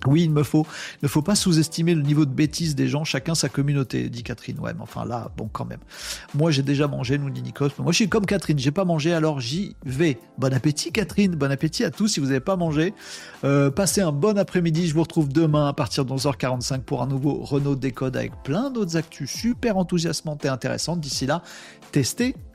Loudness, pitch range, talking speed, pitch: -23 LUFS, 140-170 Hz, 225 wpm, 155 Hz